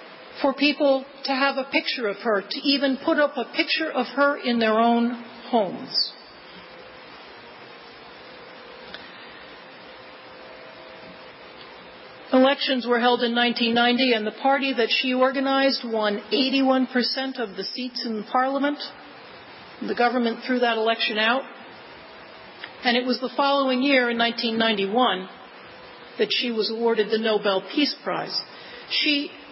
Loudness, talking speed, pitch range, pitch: -22 LUFS, 135 wpm, 230-275 Hz, 250 Hz